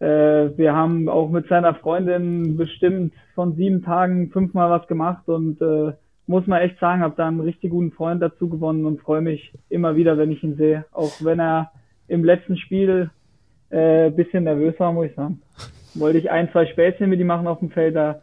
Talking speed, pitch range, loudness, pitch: 205 wpm, 155-175 Hz, -20 LUFS, 165 Hz